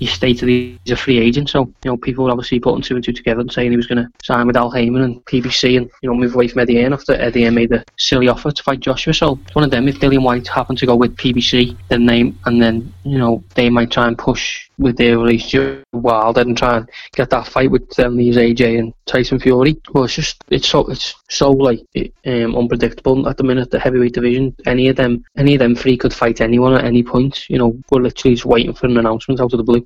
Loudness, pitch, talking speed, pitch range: -15 LUFS, 125 Hz, 260 wpm, 120-130 Hz